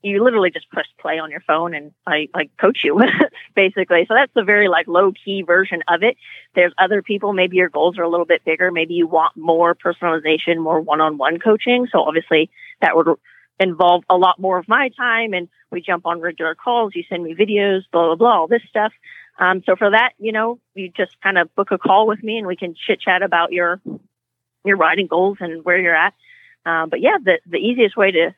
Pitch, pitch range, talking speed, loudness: 180 Hz, 170-205 Hz, 225 wpm, -17 LUFS